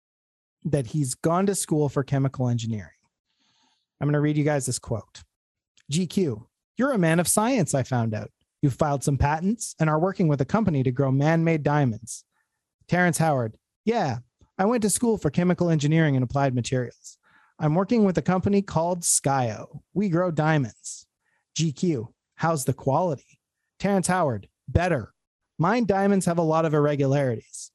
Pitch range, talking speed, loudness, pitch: 135-180 Hz, 165 wpm, -24 LUFS, 155 Hz